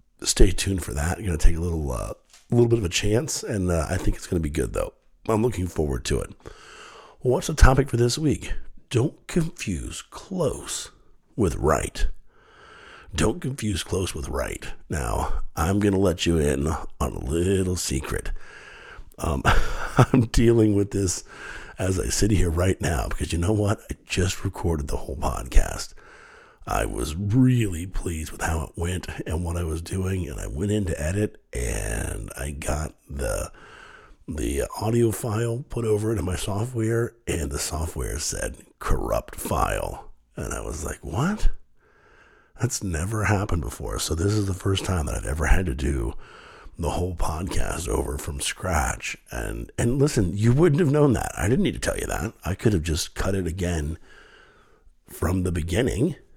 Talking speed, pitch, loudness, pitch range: 180 wpm, 90 Hz, -25 LUFS, 80-110 Hz